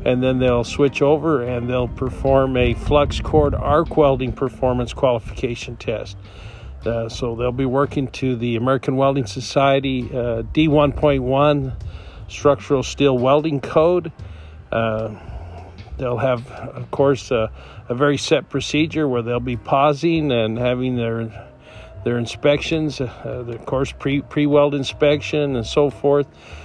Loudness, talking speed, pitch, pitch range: -19 LUFS, 135 wpm, 130 Hz, 115-145 Hz